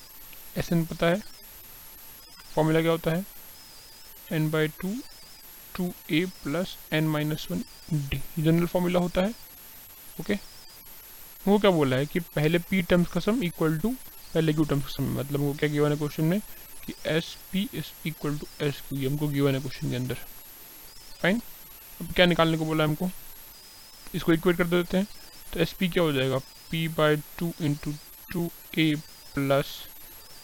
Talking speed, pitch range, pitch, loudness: 175 wpm, 150-180 Hz, 165 Hz, -27 LUFS